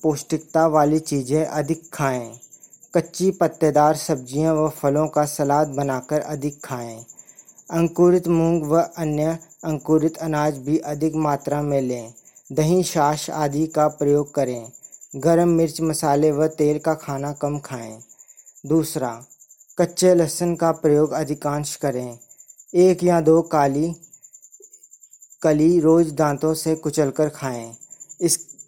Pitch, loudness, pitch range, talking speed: 155 Hz, -21 LUFS, 145-165 Hz, 125 wpm